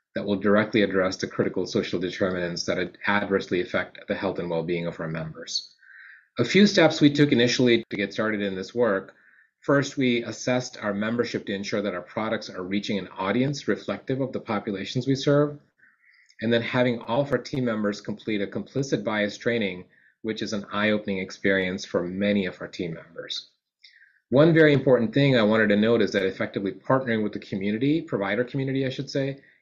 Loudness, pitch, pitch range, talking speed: -25 LUFS, 110 Hz, 100-130 Hz, 195 wpm